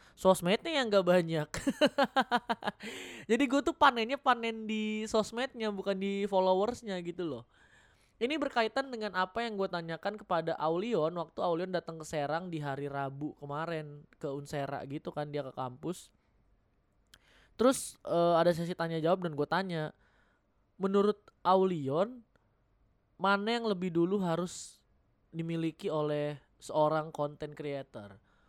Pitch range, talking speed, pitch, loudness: 150-215 Hz, 130 wpm, 175 Hz, -32 LUFS